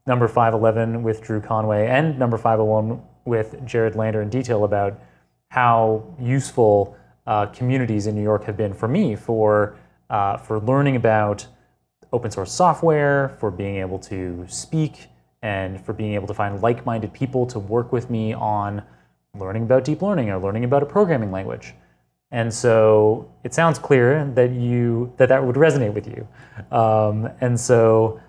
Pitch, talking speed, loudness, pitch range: 110 Hz, 165 wpm, -20 LUFS, 105-125 Hz